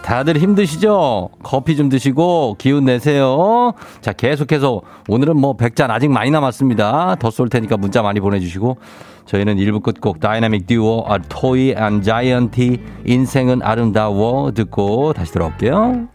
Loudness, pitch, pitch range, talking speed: -16 LUFS, 125 Hz, 110-145 Hz, 325 characters per minute